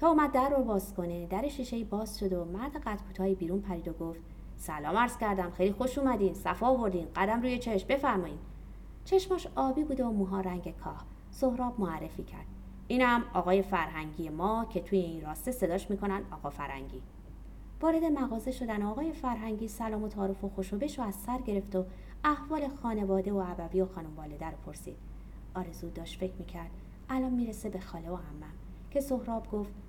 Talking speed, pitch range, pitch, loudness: 175 wpm, 180-245 Hz, 200 Hz, -33 LUFS